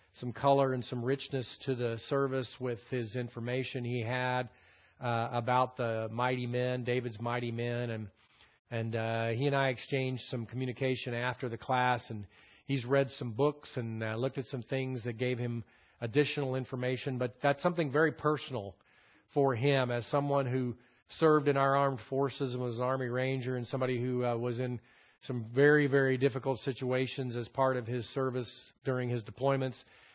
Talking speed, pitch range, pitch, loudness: 175 wpm, 120-135 Hz, 125 Hz, -33 LUFS